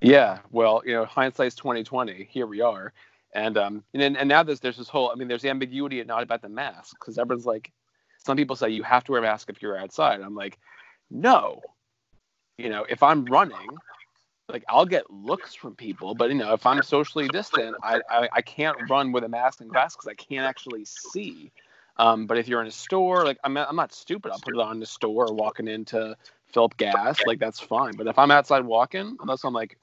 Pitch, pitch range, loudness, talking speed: 125 Hz, 115-140 Hz, -24 LUFS, 230 wpm